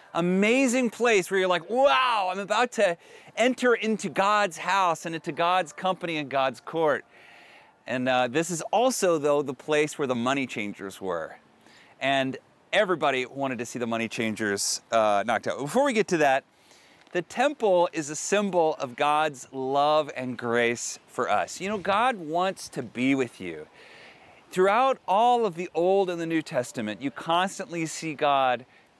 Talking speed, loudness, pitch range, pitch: 170 wpm, -26 LUFS, 135-195 Hz, 165 Hz